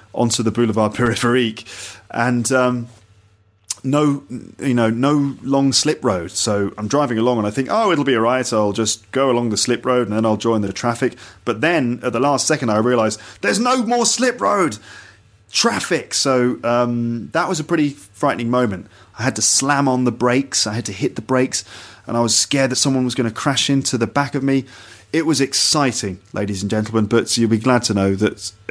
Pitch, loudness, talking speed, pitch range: 120 Hz, -18 LUFS, 225 wpm, 110-135 Hz